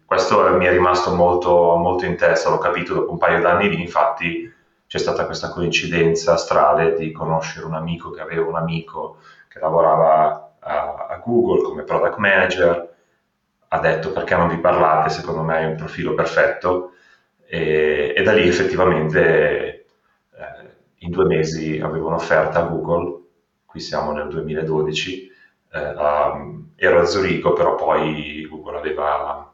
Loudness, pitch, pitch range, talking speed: -18 LUFS, 85 Hz, 80-90 Hz, 150 wpm